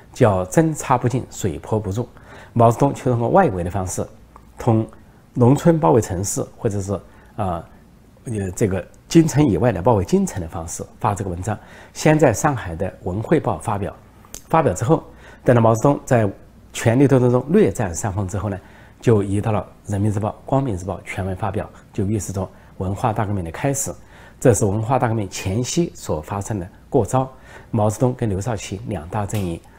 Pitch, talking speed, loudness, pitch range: 110 Hz, 275 characters per minute, -20 LUFS, 100-125 Hz